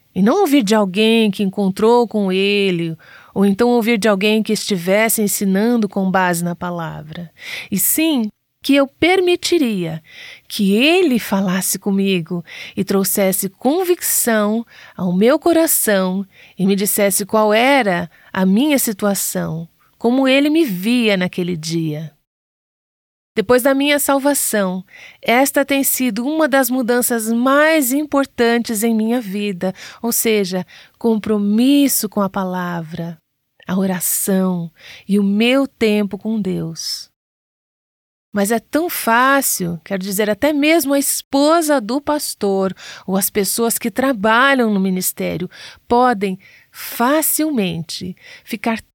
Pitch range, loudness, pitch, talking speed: 190-265 Hz, -16 LUFS, 215 Hz, 125 wpm